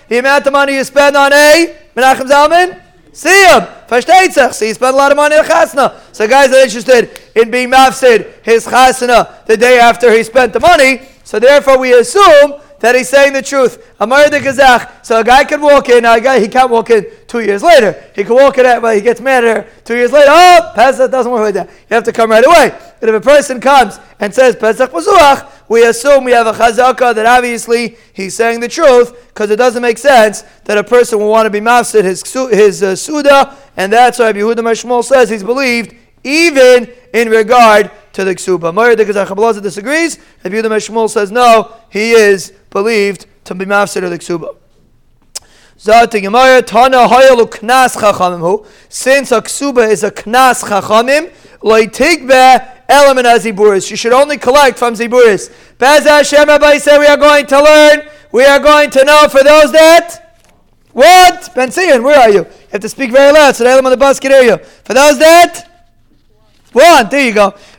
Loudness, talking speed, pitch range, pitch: -8 LUFS, 200 wpm, 225-285 Hz, 255 Hz